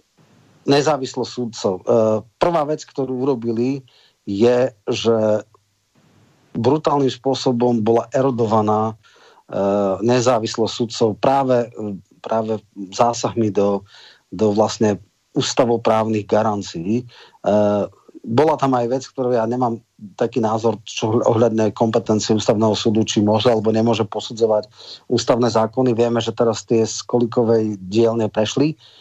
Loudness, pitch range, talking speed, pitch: -19 LUFS, 110-125 Hz, 105 wpm, 115 Hz